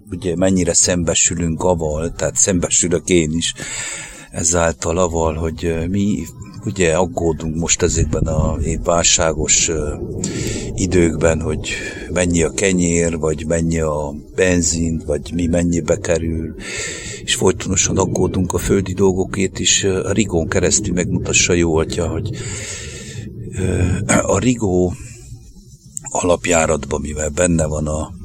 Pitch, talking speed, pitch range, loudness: 85 Hz, 110 wpm, 80-95 Hz, -17 LUFS